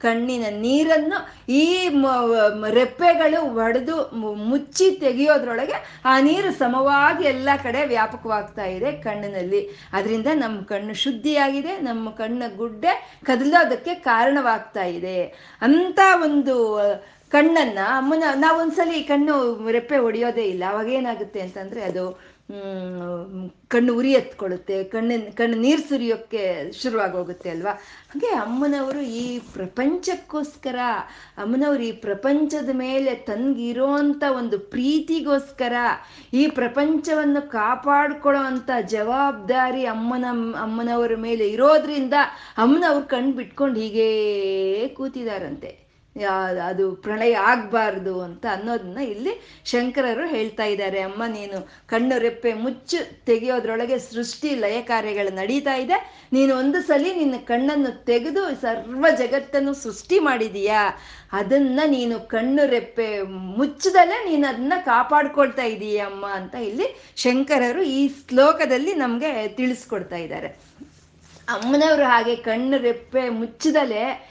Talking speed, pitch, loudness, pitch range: 100 wpm, 250 Hz, -21 LUFS, 220-285 Hz